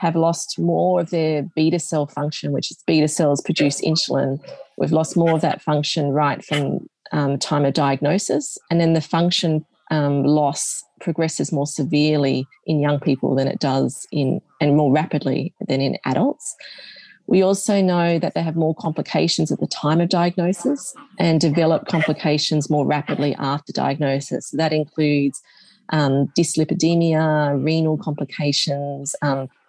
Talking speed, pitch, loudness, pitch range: 155 wpm, 155 Hz, -20 LUFS, 145-165 Hz